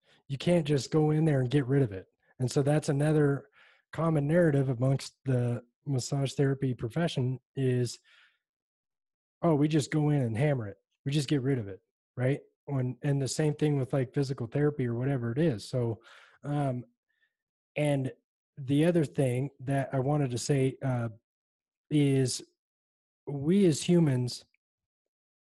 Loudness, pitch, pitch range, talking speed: -29 LUFS, 140 Hz, 130-150 Hz, 160 wpm